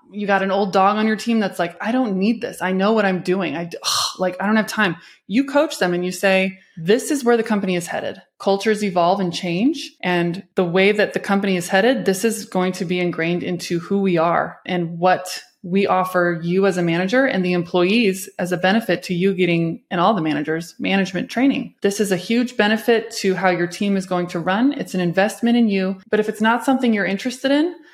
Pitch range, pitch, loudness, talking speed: 180-220 Hz, 195 Hz, -19 LUFS, 235 wpm